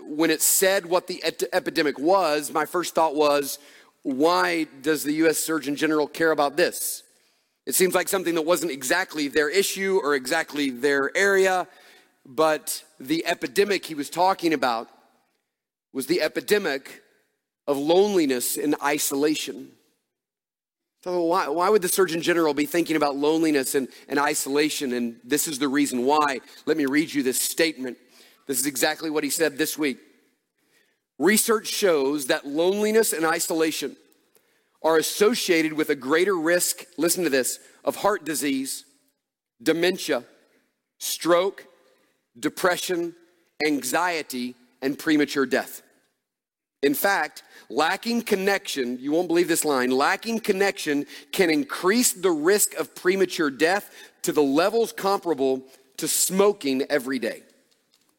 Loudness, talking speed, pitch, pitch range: -23 LUFS, 135 wpm, 160 Hz, 145-185 Hz